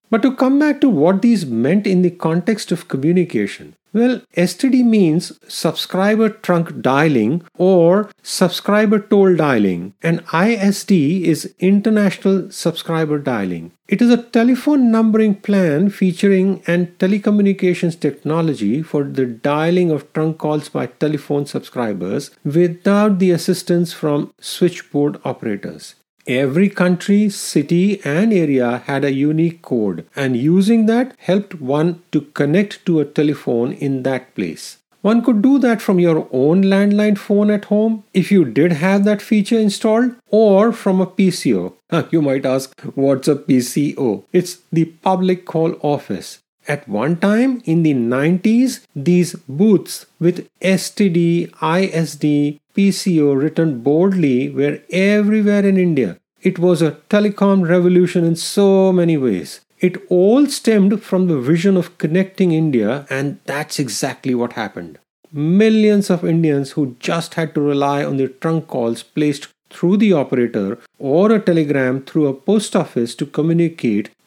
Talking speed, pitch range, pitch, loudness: 140 wpm, 150-200 Hz, 175 Hz, -16 LUFS